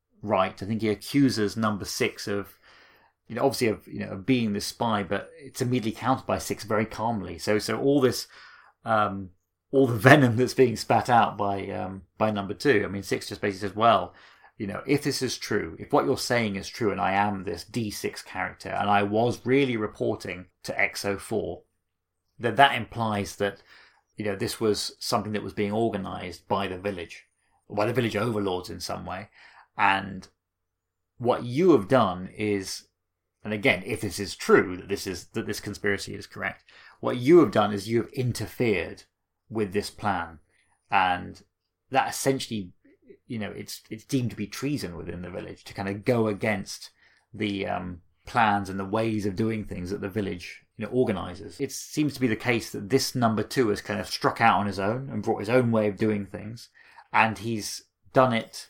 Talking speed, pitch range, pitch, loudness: 200 wpm, 95-115 Hz, 105 Hz, -26 LUFS